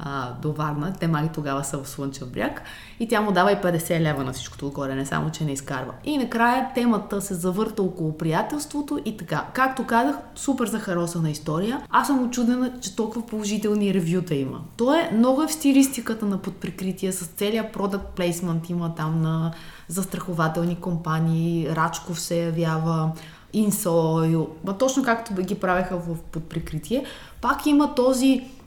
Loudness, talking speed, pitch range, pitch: -24 LUFS, 160 wpm, 160-230 Hz, 180 Hz